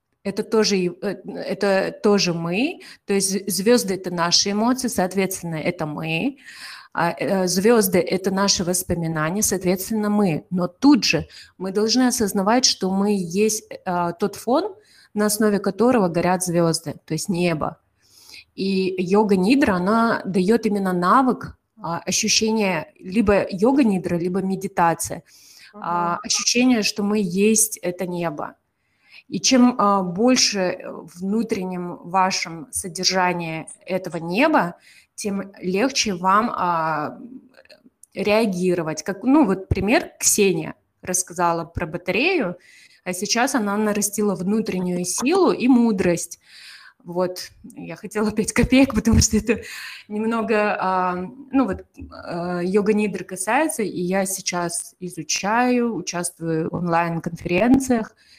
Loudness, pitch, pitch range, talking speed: -21 LUFS, 195 Hz, 180-225 Hz, 115 wpm